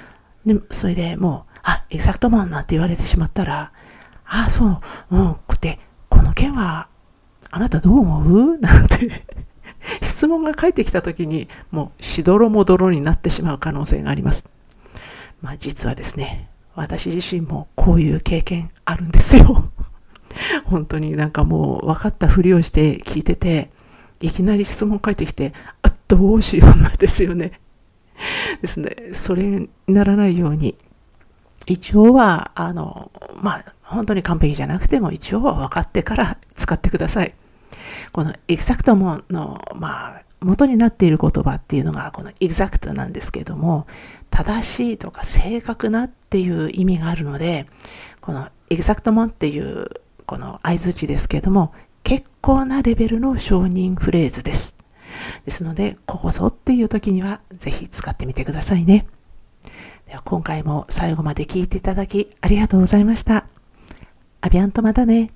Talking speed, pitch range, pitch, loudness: 330 characters per minute, 160-210 Hz, 185 Hz, -18 LUFS